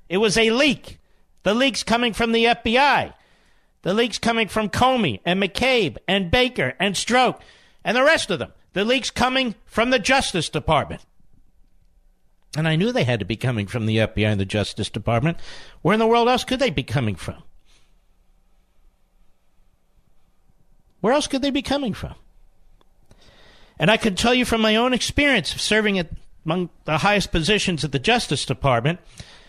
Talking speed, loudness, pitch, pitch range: 175 wpm, -20 LUFS, 200 Hz, 145-240 Hz